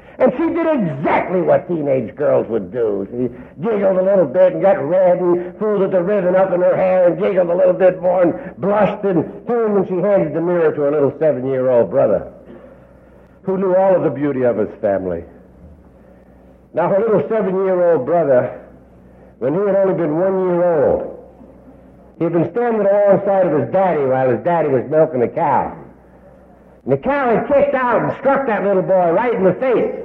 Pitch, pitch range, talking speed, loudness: 185 Hz, 140-200 Hz, 195 wpm, -16 LUFS